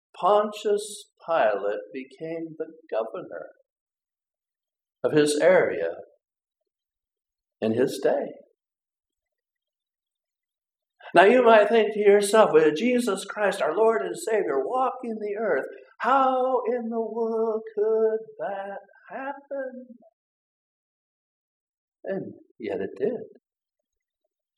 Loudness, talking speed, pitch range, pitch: -23 LUFS, 95 wpm, 210-315 Hz, 230 Hz